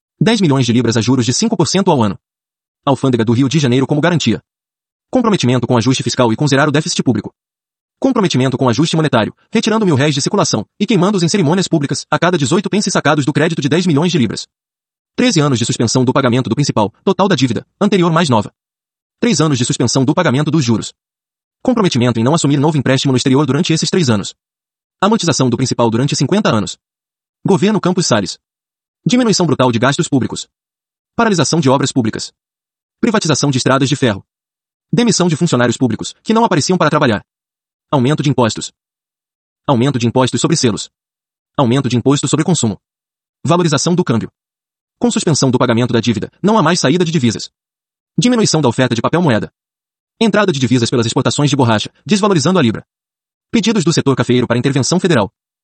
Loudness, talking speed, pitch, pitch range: -14 LUFS, 185 wpm, 145 Hz, 125-180 Hz